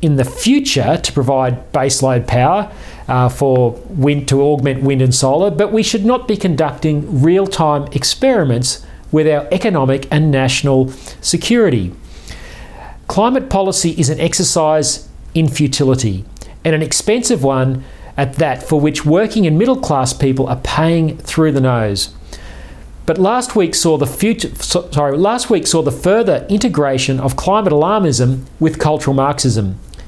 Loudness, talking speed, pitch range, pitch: -14 LUFS, 145 wpm, 130-170 Hz, 150 Hz